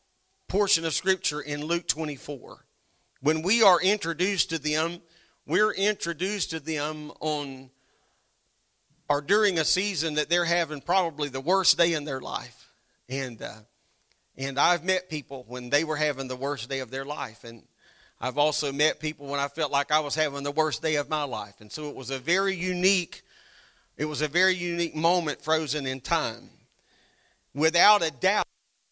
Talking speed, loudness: 175 wpm, -26 LUFS